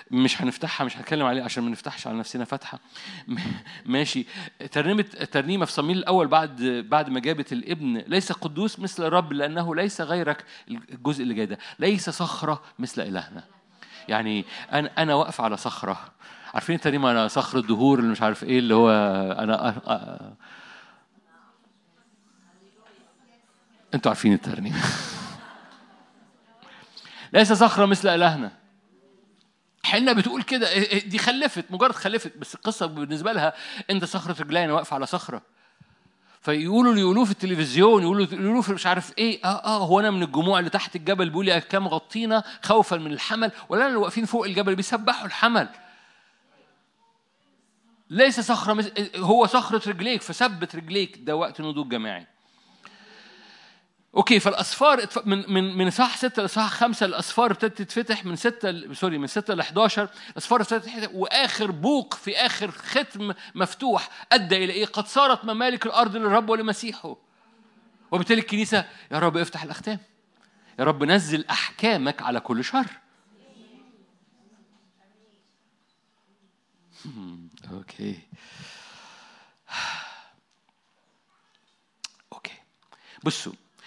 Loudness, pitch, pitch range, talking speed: -23 LUFS, 200 Hz, 170-225 Hz, 125 wpm